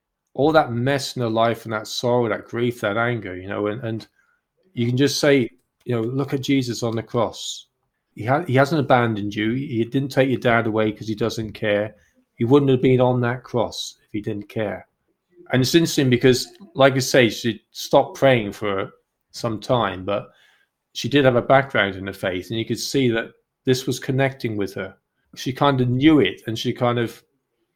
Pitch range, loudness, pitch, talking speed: 110-135 Hz, -21 LUFS, 120 Hz, 210 wpm